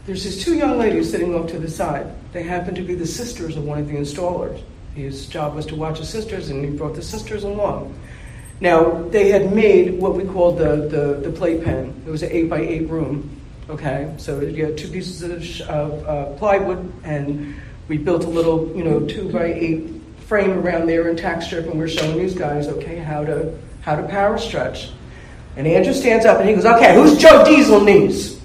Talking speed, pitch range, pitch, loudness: 215 wpm, 150-185 Hz, 165 Hz, -17 LUFS